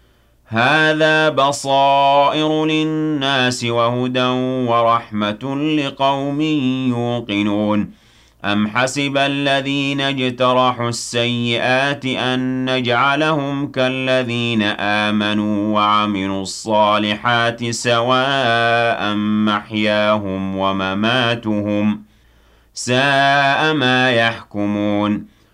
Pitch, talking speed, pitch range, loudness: 120 Hz, 55 wpm, 105-135 Hz, -17 LUFS